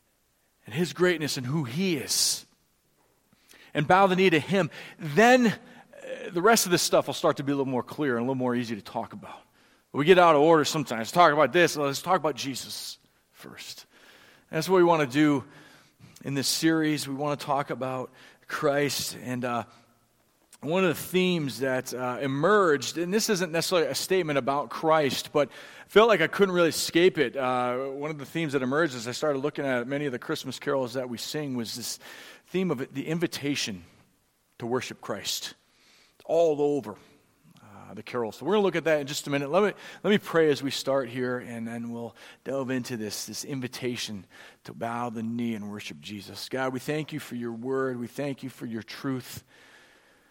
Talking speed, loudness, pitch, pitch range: 205 wpm, -26 LUFS, 140 Hz, 125-165 Hz